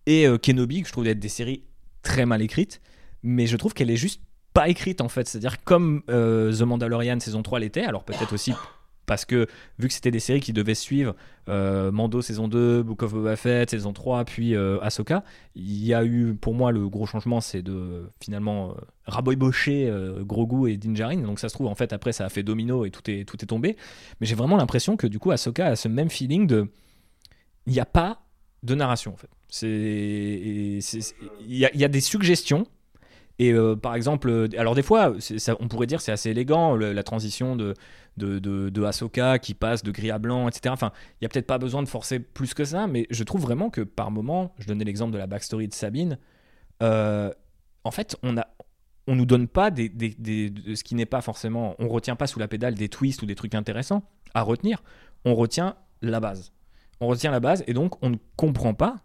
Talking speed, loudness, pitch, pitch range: 230 wpm, -25 LUFS, 115 Hz, 105-130 Hz